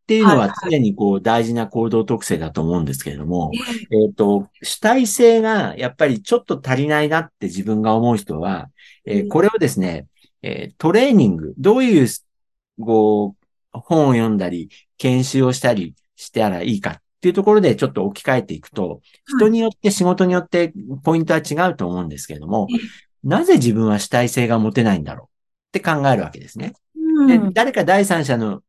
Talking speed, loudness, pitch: 365 characters per minute, -17 LUFS, 130 Hz